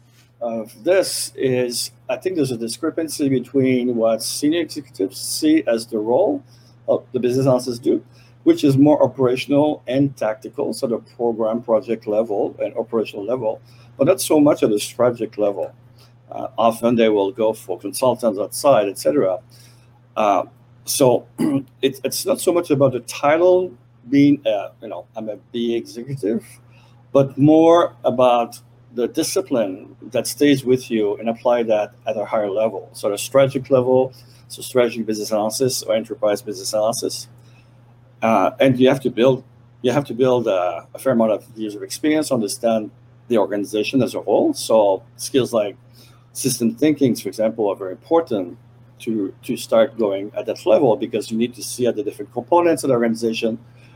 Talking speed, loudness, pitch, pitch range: 165 wpm, -19 LUFS, 120 Hz, 115-130 Hz